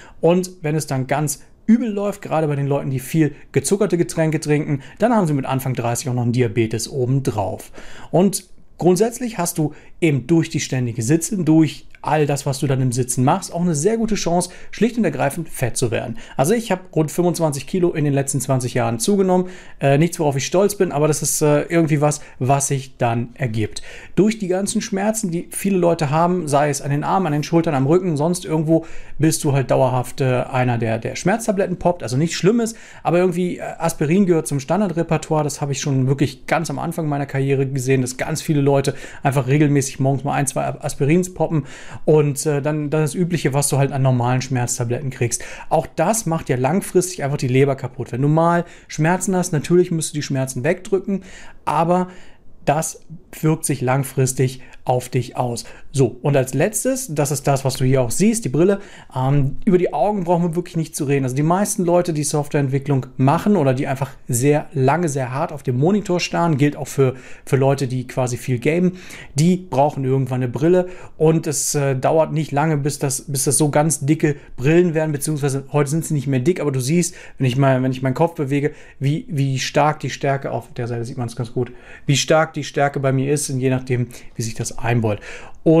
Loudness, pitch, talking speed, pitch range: -19 LUFS, 150 Hz, 210 wpm, 135-170 Hz